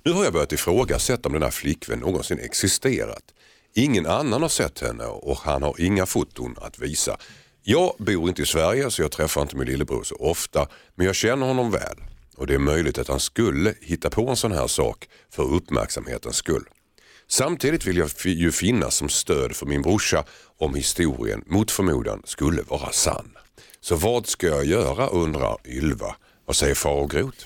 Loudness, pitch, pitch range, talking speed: -23 LUFS, 85 Hz, 70-95 Hz, 185 wpm